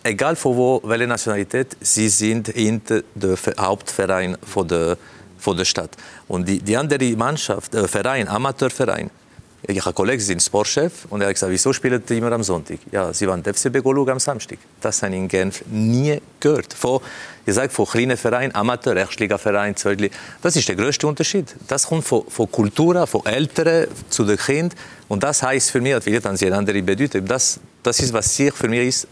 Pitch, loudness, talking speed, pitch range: 115 Hz, -19 LUFS, 175 wpm, 100-135 Hz